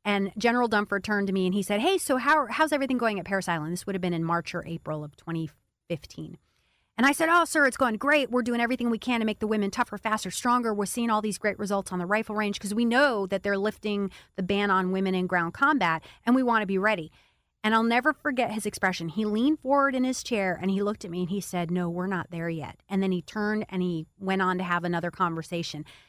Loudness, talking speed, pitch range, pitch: -27 LUFS, 260 wpm, 180-235 Hz, 200 Hz